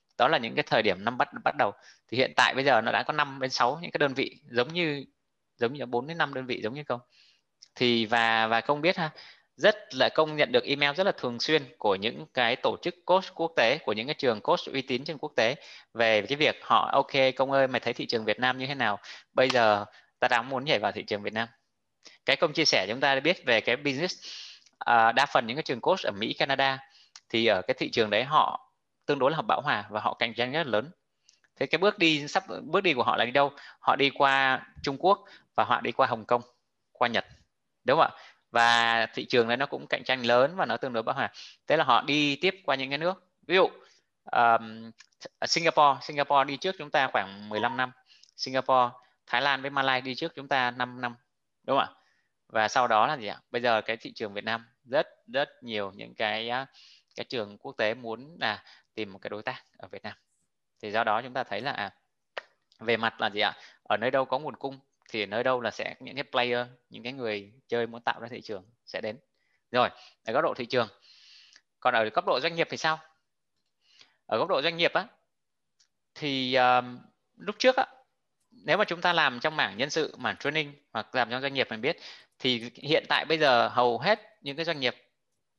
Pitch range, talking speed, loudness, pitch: 120-150 Hz, 240 wpm, -27 LUFS, 130 Hz